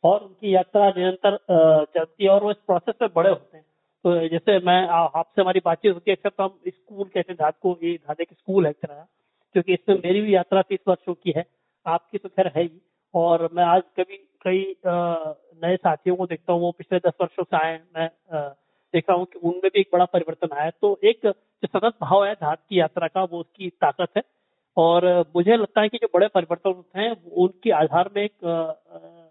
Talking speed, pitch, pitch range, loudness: 205 wpm, 180 Hz, 170-195 Hz, -22 LUFS